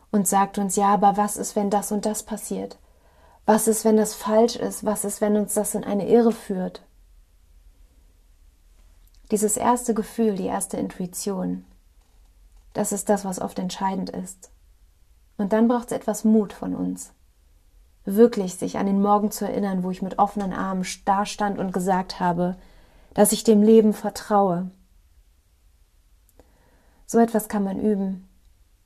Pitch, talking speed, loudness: 195 Hz, 155 wpm, -23 LUFS